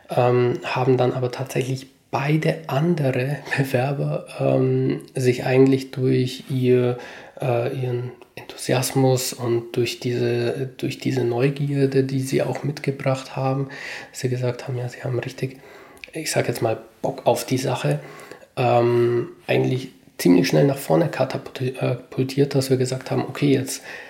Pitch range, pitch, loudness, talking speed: 125-135 Hz, 130 Hz, -22 LUFS, 135 wpm